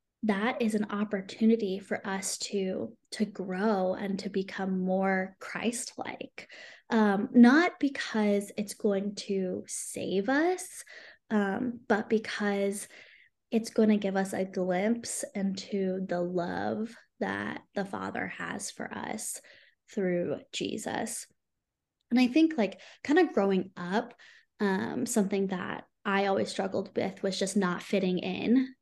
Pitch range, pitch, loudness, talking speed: 195-230 Hz, 205 Hz, -30 LUFS, 130 wpm